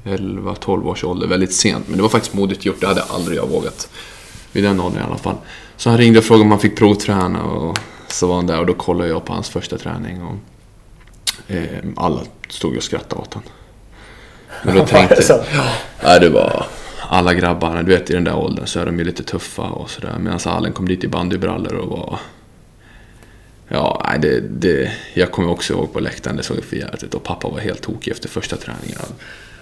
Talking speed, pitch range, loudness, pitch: 210 wpm, 90-110 Hz, -17 LUFS, 100 Hz